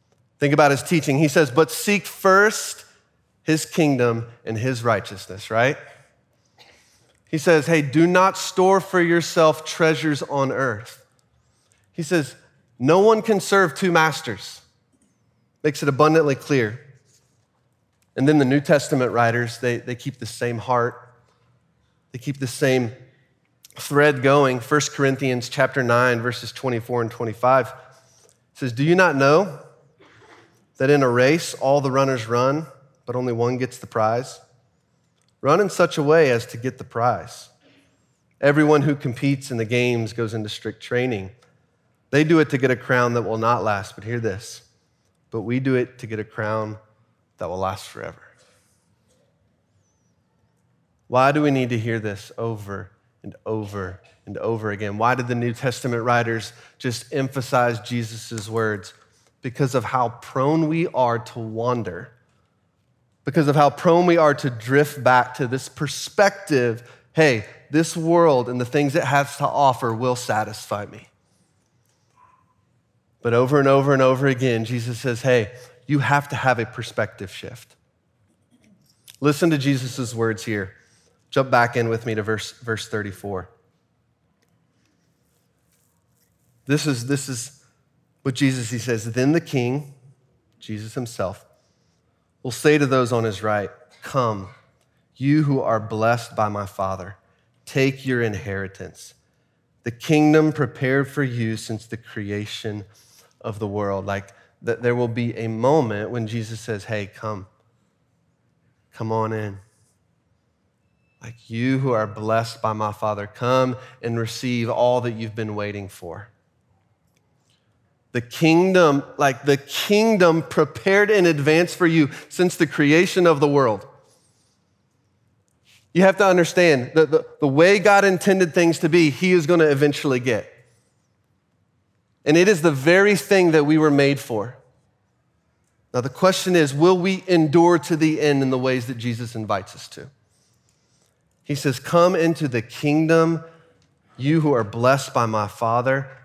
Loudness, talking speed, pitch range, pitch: -20 LUFS, 150 wpm, 115-150 Hz, 130 Hz